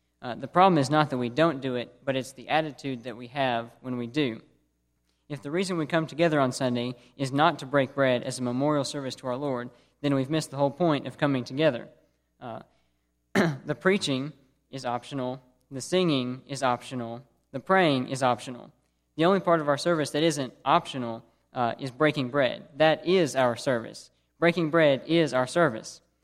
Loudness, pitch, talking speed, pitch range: -26 LUFS, 135 Hz, 190 wpm, 125-155 Hz